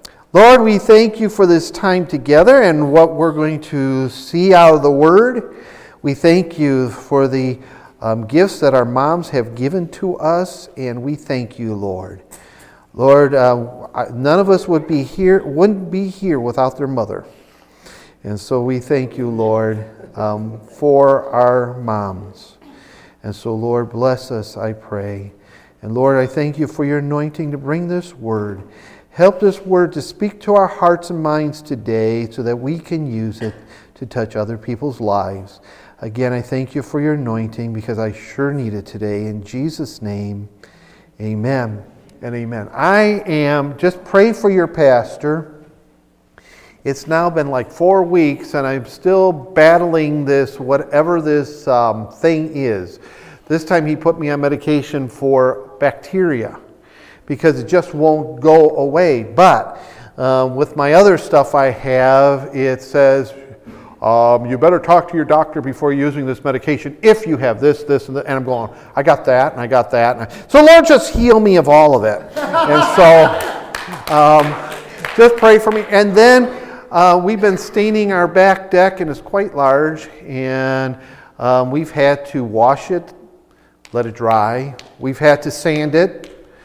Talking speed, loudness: 170 wpm, -14 LUFS